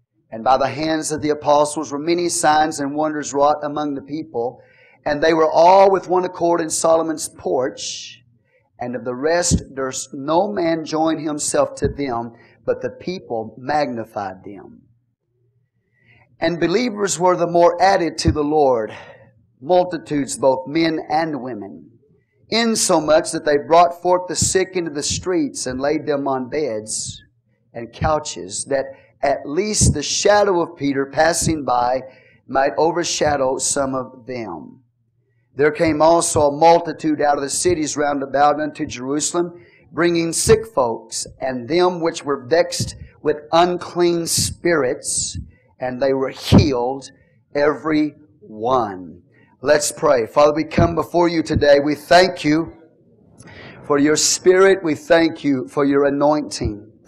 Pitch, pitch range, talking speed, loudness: 150 Hz, 130-165 Hz, 145 wpm, -18 LUFS